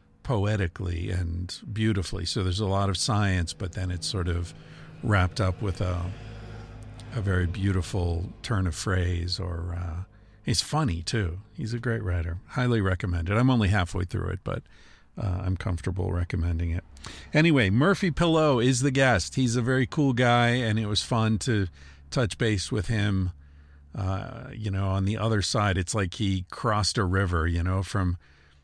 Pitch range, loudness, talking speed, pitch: 90-110 Hz, -27 LUFS, 170 wpm, 100 Hz